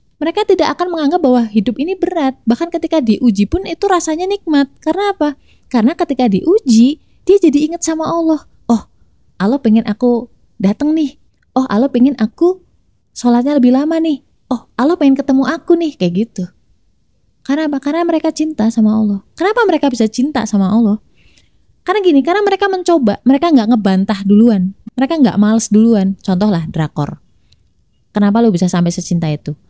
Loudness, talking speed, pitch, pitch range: -14 LUFS, 165 wpm, 265 Hz, 220-325 Hz